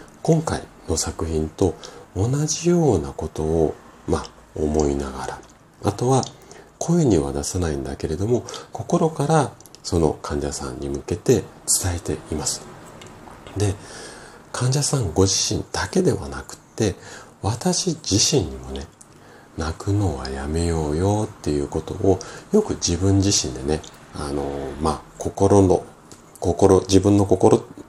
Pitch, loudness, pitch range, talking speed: 95 Hz, -22 LUFS, 75-115 Hz, 235 characters per minute